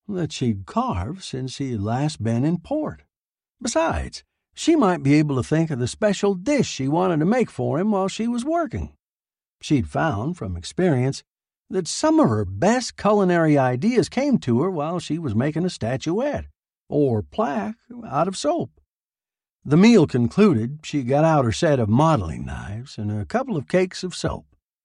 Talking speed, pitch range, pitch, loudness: 175 wpm, 125-205 Hz, 160 Hz, -22 LUFS